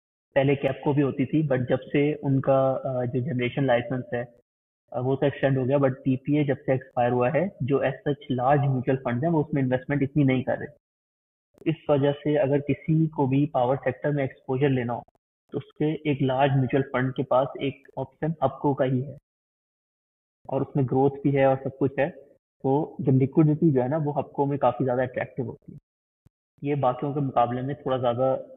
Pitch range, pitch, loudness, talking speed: 130-145 Hz, 135 Hz, -25 LUFS, 215 wpm